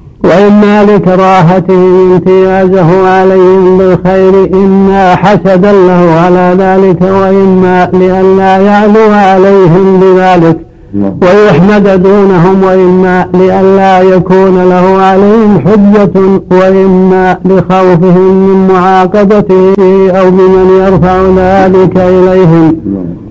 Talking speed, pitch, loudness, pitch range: 80 wpm, 190 Hz, -4 LUFS, 185-190 Hz